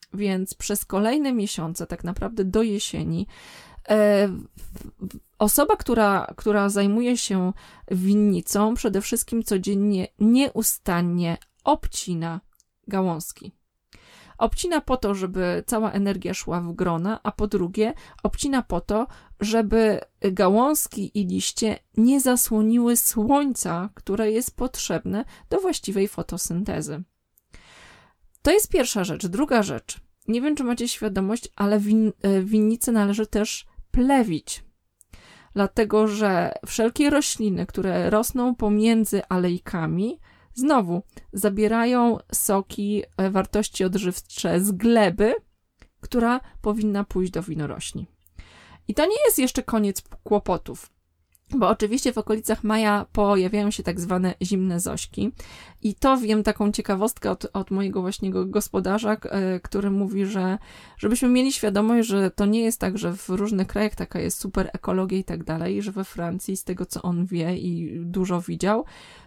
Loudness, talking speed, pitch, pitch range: -23 LUFS, 125 wpm, 205 Hz, 185-225 Hz